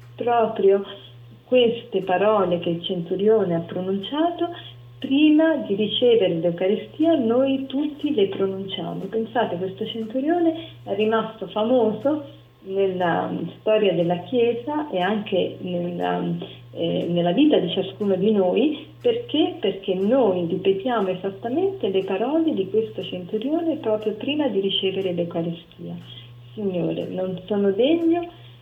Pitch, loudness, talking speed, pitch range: 200 Hz, -22 LUFS, 115 wpm, 180-255 Hz